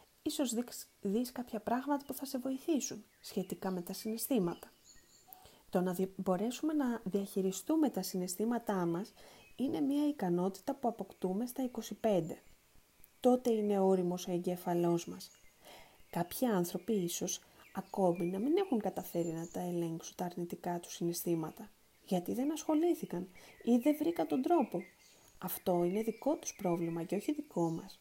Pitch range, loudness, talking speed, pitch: 180-250 Hz, -36 LUFS, 140 wpm, 200 Hz